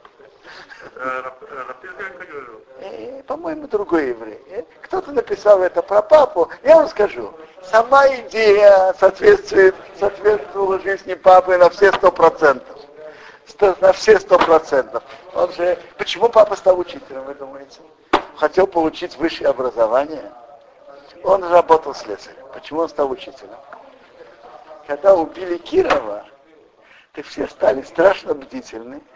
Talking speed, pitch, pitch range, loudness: 110 wpm, 190 Hz, 160-230 Hz, -16 LUFS